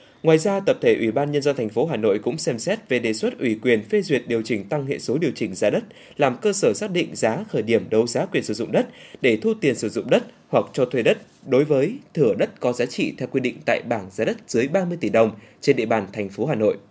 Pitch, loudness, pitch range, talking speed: 130 Hz, -22 LUFS, 110-160 Hz, 285 wpm